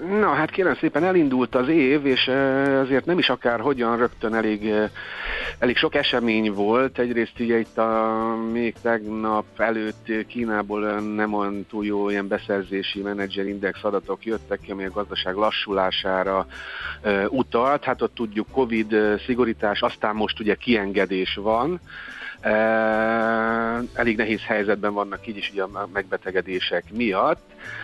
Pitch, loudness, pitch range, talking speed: 110 Hz, -23 LUFS, 100-120 Hz, 135 wpm